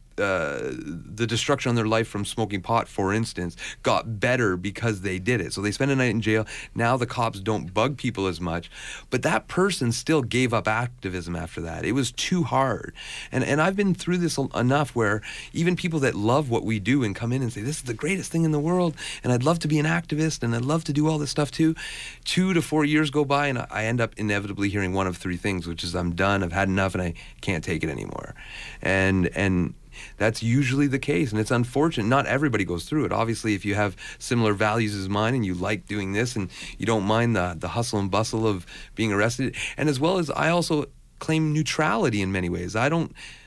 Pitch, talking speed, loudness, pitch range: 115 Hz, 235 wpm, -25 LUFS, 100-145 Hz